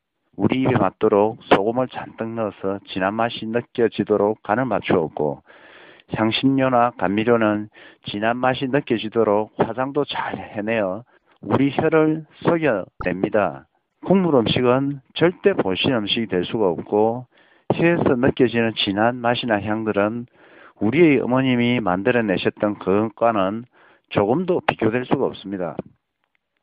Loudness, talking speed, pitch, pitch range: -20 LUFS, 275 characters per minute, 115 Hz, 105-130 Hz